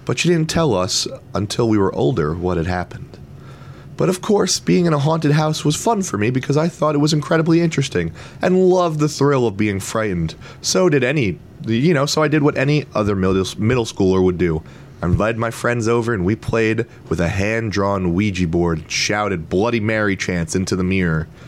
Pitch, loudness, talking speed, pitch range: 115 Hz, -18 LUFS, 205 wpm, 95-150 Hz